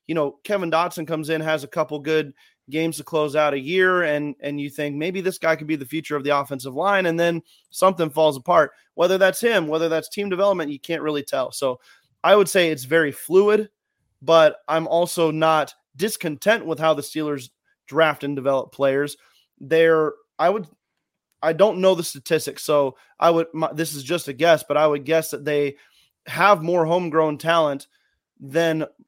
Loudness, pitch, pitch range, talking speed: -21 LUFS, 160 Hz, 145-170 Hz, 195 wpm